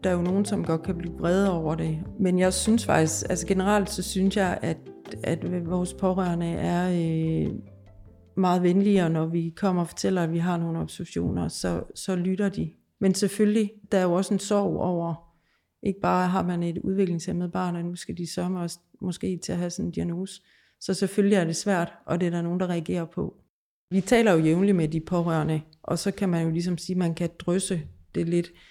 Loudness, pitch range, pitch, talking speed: -26 LUFS, 170-190 Hz, 180 Hz, 215 wpm